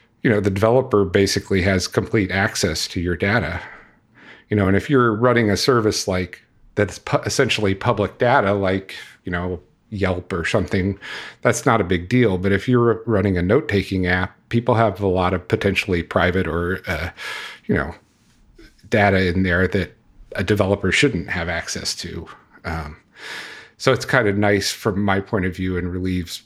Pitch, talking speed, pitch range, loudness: 100 Hz, 175 wpm, 90-110 Hz, -20 LUFS